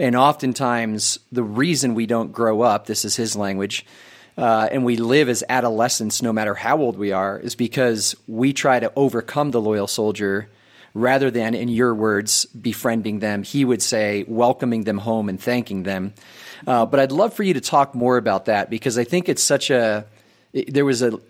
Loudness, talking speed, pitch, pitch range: -20 LUFS, 195 wpm, 115 Hz, 110-125 Hz